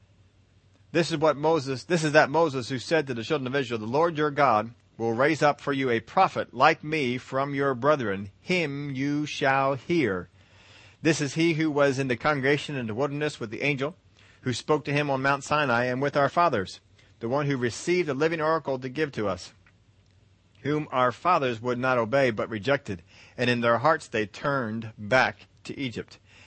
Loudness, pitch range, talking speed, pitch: -26 LUFS, 110-150 Hz, 200 wpm, 135 Hz